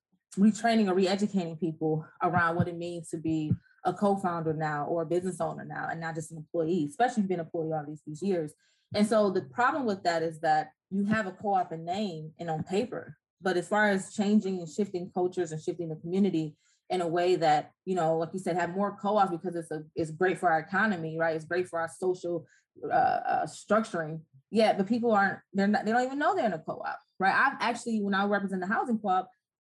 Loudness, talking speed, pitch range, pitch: -29 LUFS, 225 wpm, 165-205 Hz, 180 Hz